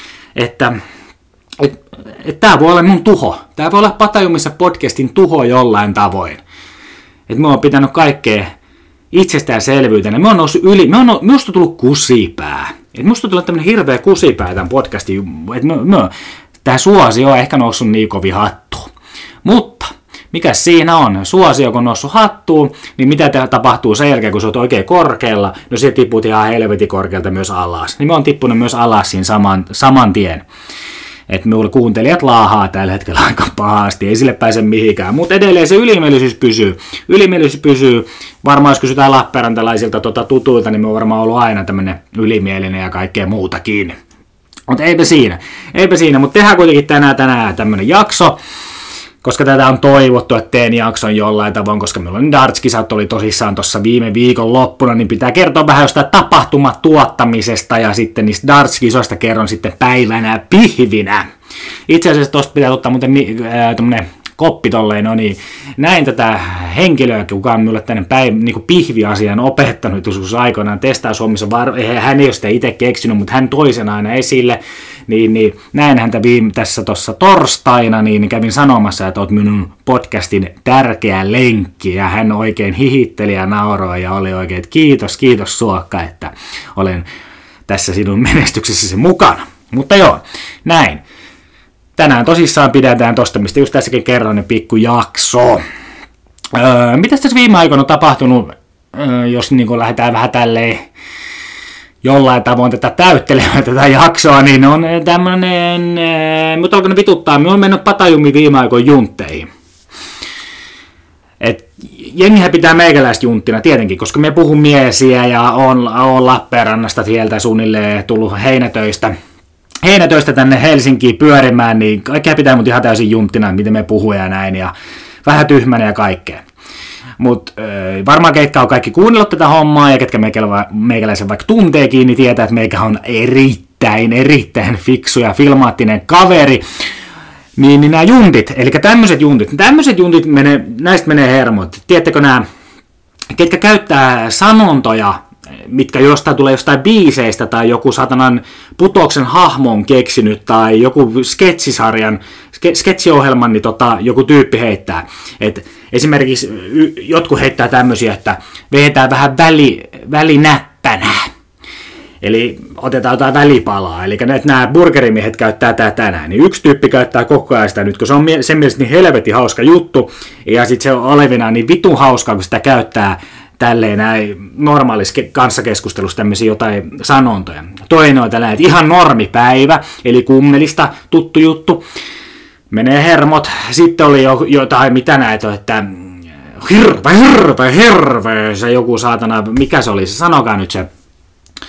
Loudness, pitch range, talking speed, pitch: -9 LUFS, 110-145 Hz, 150 wpm, 125 Hz